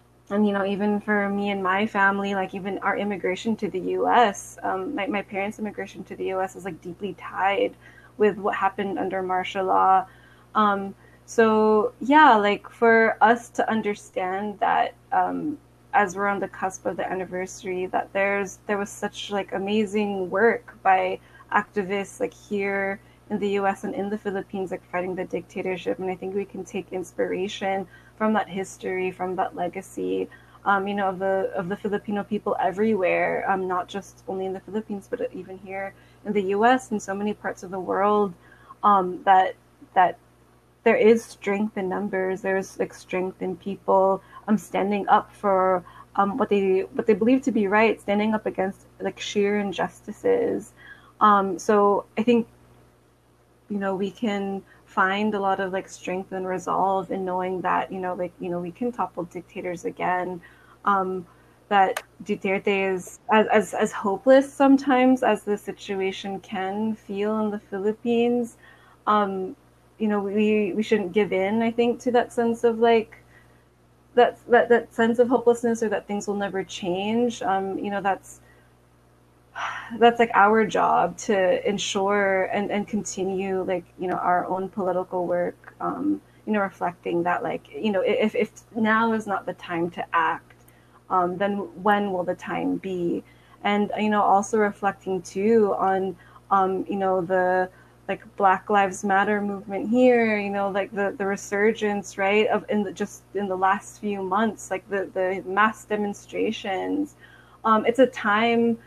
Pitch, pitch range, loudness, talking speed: 200 Hz, 185-210 Hz, -24 LUFS, 170 wpm